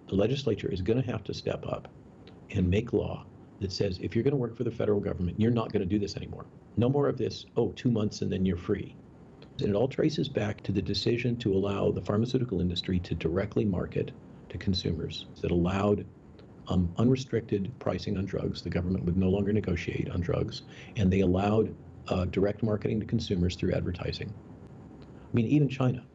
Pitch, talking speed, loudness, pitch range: 105 Hz, 200 wpm, -30 LUFS, 95-115 Hz